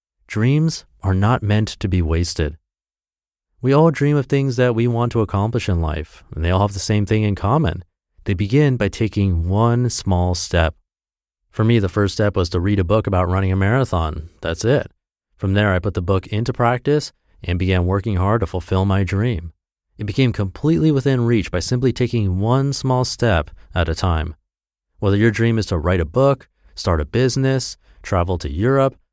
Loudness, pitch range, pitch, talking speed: -19 LUFS, 90-120 Hz, 100 Hz, 195 wpm